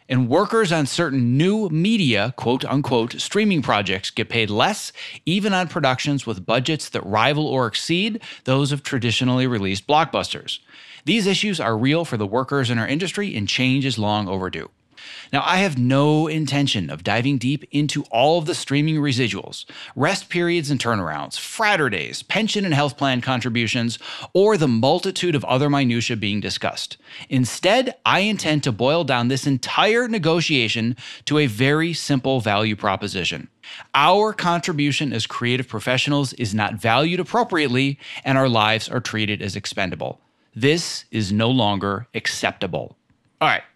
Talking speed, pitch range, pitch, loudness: 155 wpm, 115-155 Hz, 135 Hz, -20 LUFS